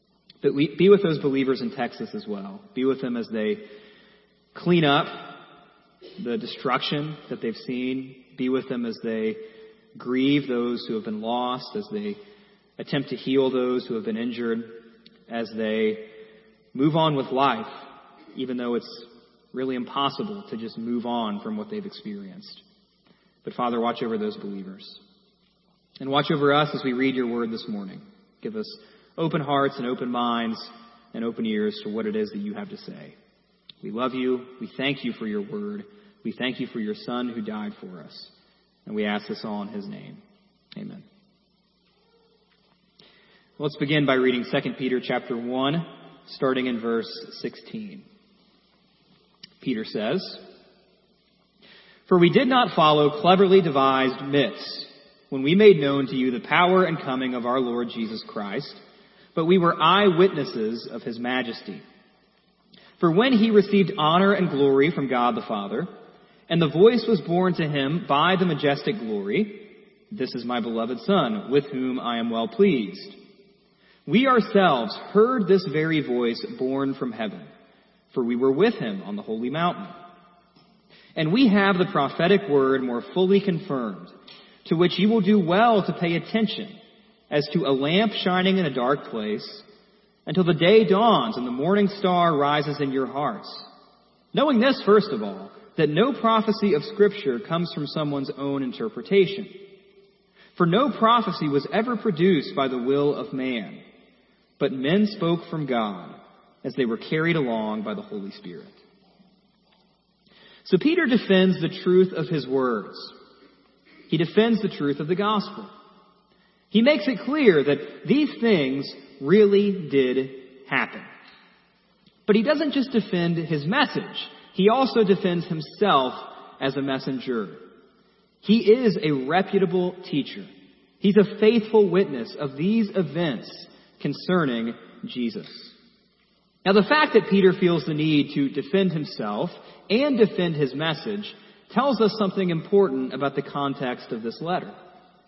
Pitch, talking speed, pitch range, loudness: 190 Hz, 155 wpm, 140-210 Hz, -23 LUFS